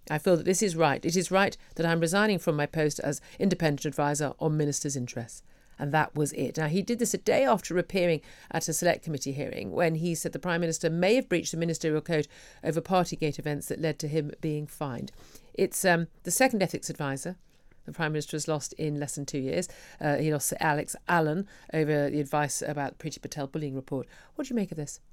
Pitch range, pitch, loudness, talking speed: 150-175 Hz, 155 Hz, -29 LUFS, 230 wpm